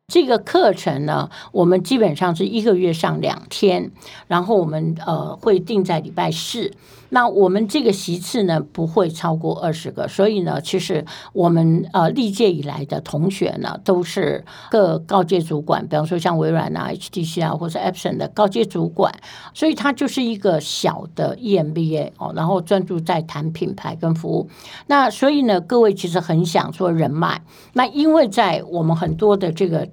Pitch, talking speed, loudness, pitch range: 185 Hz, 275 characters per minute, -19 LUFS, 165-210 Hz